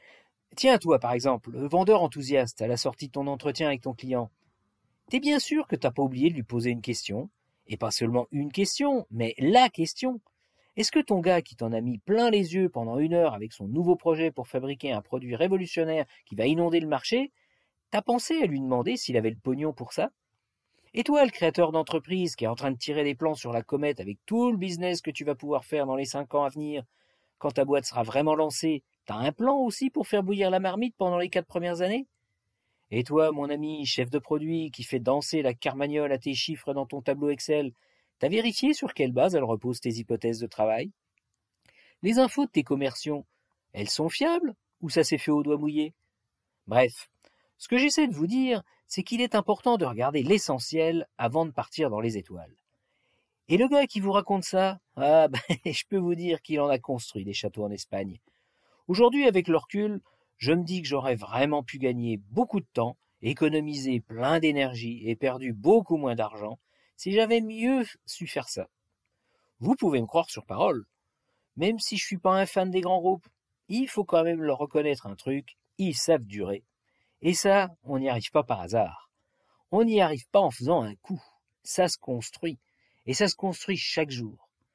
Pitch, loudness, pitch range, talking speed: 150 Hz, -27 LUFS, 125-185 Hz, 205 wpm